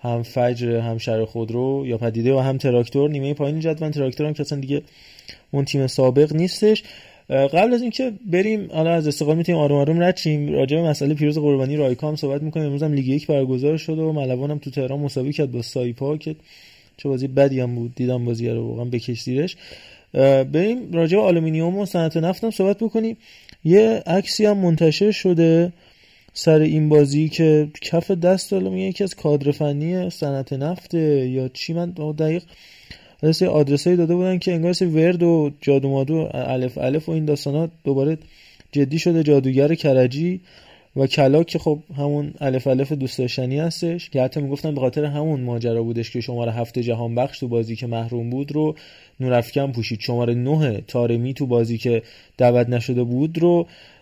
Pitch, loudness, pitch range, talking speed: 145 Hz, -20 LUFS, 130-165 Hz, 175 wpm